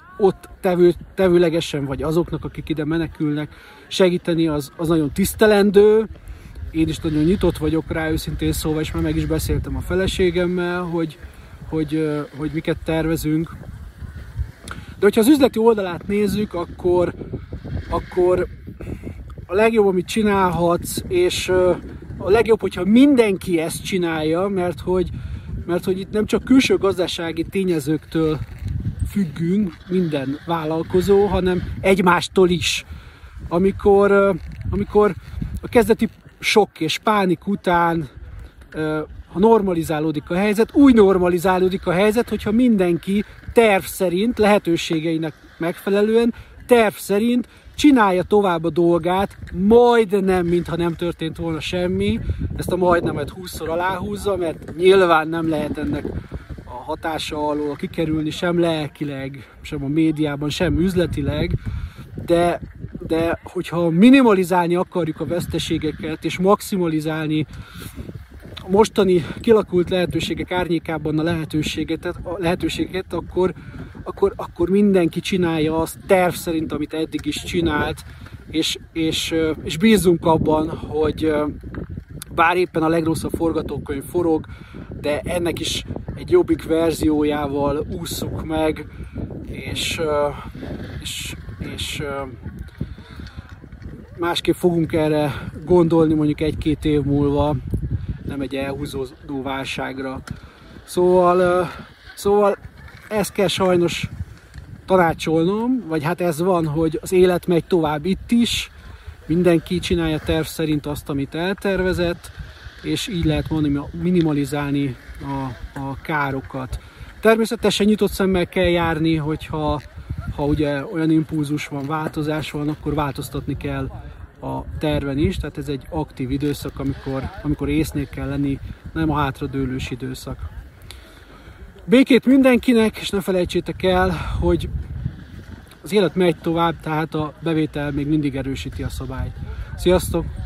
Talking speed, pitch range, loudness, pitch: 115 wpm, 145-185 Hz, -20 LUFS, 165 Hz